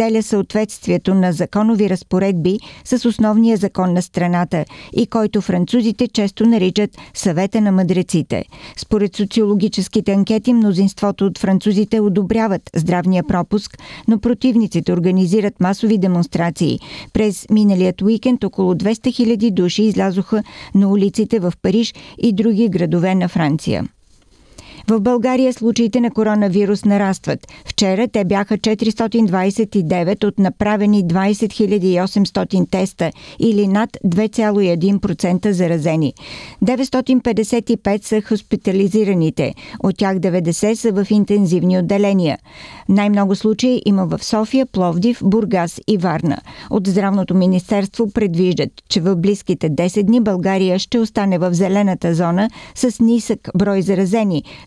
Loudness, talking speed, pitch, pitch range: -16 LUFS, 115 wpm, 200 Hz, 185-220 Hz